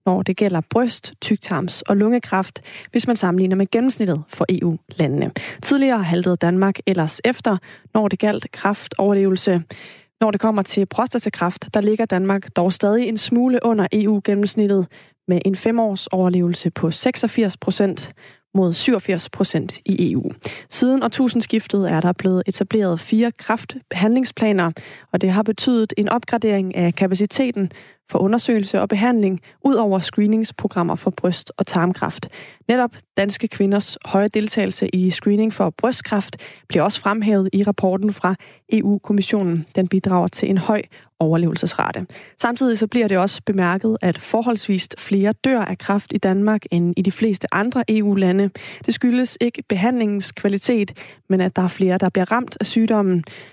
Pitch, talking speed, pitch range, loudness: 200 Hz, 150 wpm, 185-220 Hz, -19 LUFS